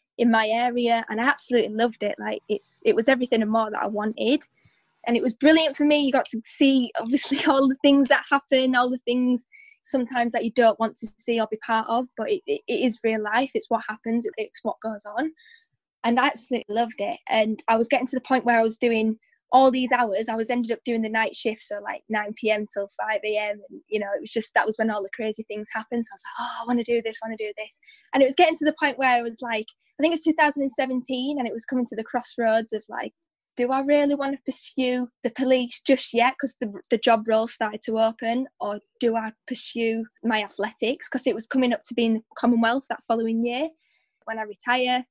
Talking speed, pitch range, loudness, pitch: 245 wpm, 225-270 Hz, -24 LUFS, 240 Hz